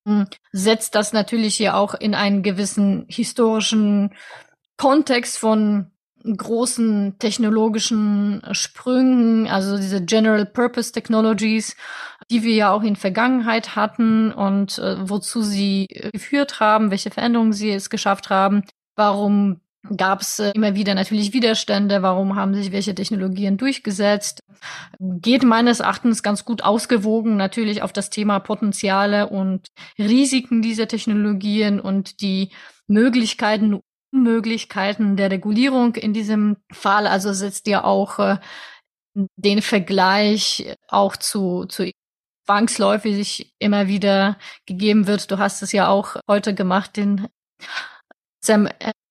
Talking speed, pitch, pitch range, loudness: 120 wpm, 210 Hz, 200-225 Hz, -19 LUFS